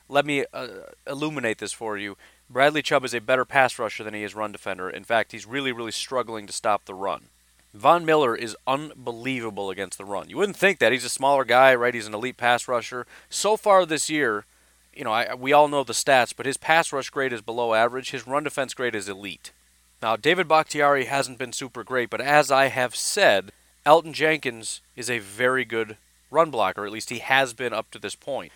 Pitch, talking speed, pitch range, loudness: 125 Hz, 220 wpm, 110-140 Hz, -23 LUFS